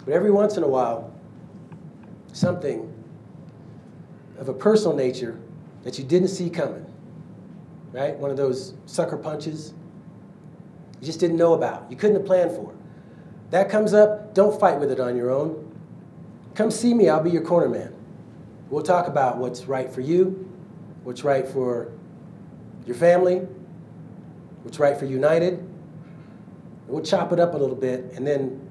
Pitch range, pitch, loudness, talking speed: 140-185 Hz, 170 Hz, -22 LUFS, 155 wpm